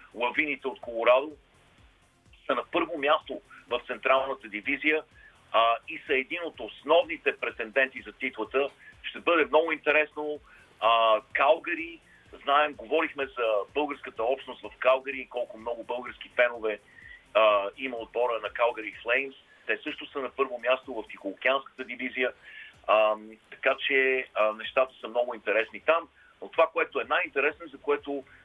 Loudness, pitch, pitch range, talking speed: -28 LUFS, 130 Hz, 115-145 Hz, 140 wpm